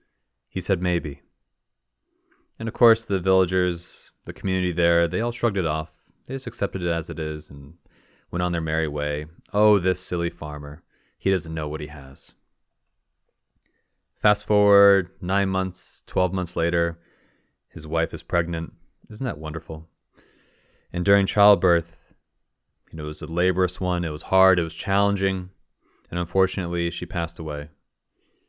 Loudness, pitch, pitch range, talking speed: -23 LUFS, 85 Hz, 80-95 Hz, 155 wpm